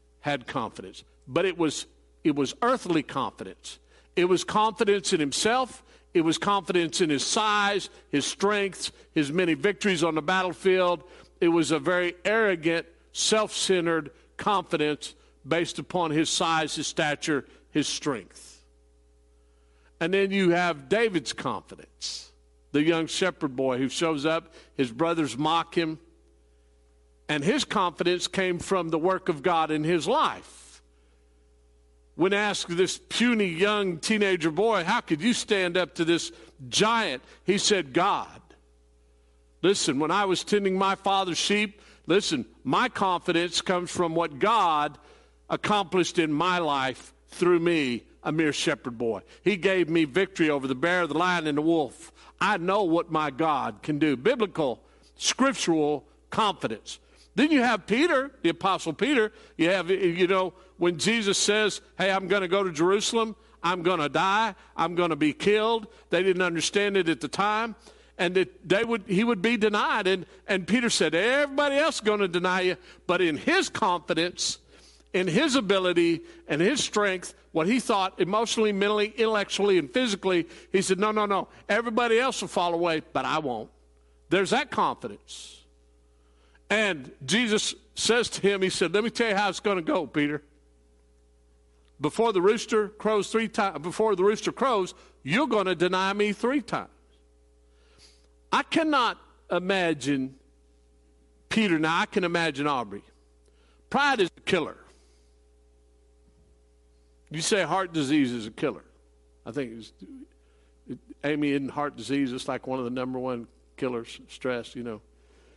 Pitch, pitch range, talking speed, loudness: 170 Hz, 130-200 Hz, 155 wpm, -26 LUFS